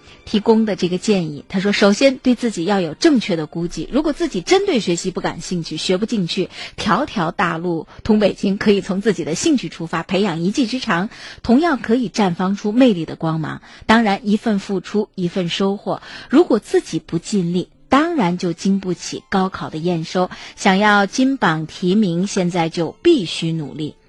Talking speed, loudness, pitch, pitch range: 280 characters per minute, -18 LUFS, 195 Hz, 170-220 Hz